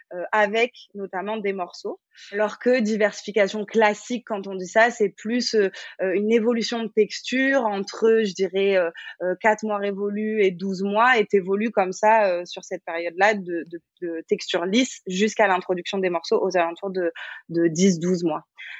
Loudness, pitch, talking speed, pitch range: -23 LUFS, 200 Hz, 170 wpm, 185-220 Hz